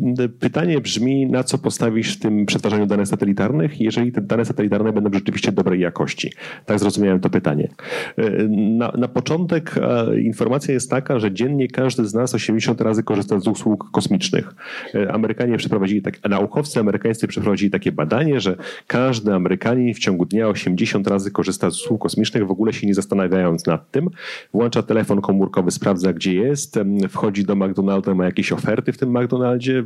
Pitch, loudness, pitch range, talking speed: 110 Hz, -19 LUFS, 100-125 Hz, 165 wpm